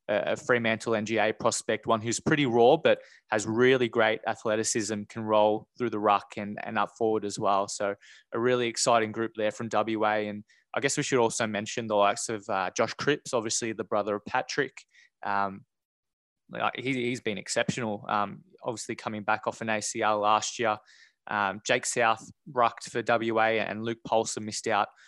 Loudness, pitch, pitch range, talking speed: -28 LUFS, 110 Hz, 105-115 Hz, 180 wpm